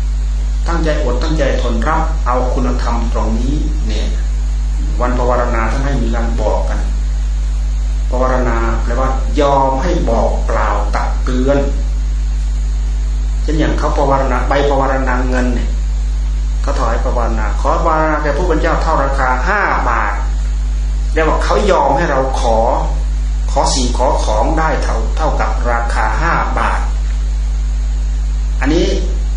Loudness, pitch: -16 LUFS, 75 Hz